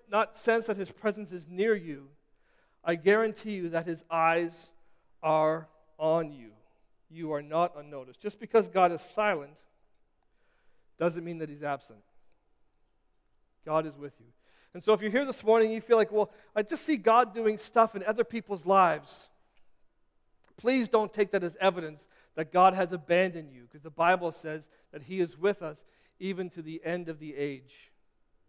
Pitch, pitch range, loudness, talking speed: 175 Hz, 155-215 Hz, -29 LUFS, 175 wpm